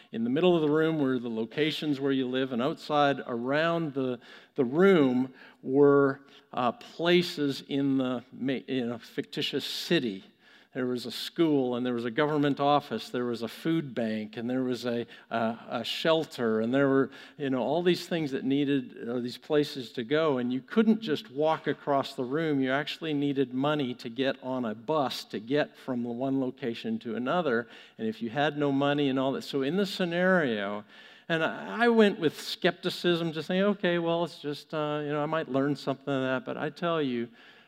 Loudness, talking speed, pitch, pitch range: -29 LUFS, 200 wpm, 140 Hz, 130-160 Hz